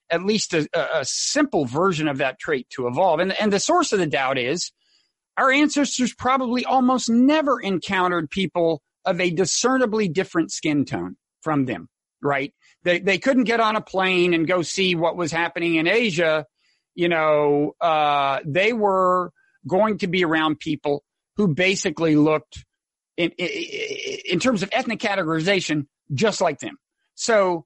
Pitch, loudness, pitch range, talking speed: 185 Hz, -21 LUFS, 160-225 Hz, 160 wpm